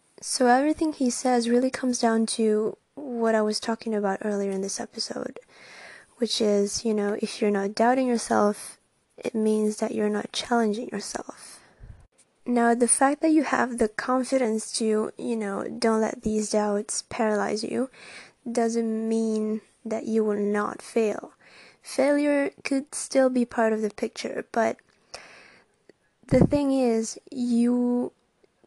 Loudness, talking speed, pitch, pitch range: -25 LUFS, 145 wpm, 230 Hz, 215-245 Hz